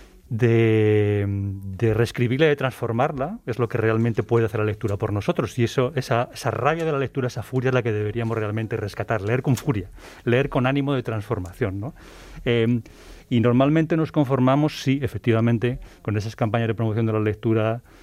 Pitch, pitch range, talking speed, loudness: 115 Hz, 110-130 Hz, 185 wpm, -23 LUFS